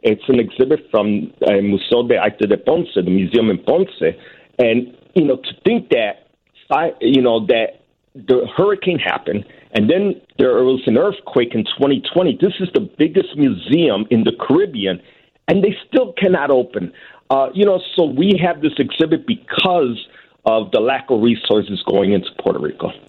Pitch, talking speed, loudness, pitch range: 135 Hz, 170 wpm, -16 LUFS, 110-185 Hz